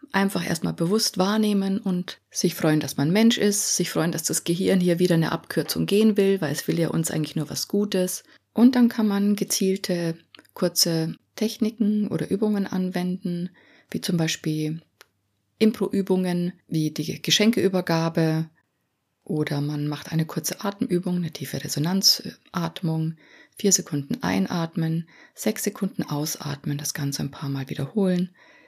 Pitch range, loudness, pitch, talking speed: 160-195 Hz, -24 LUFS, 175 Hz, 145 wpm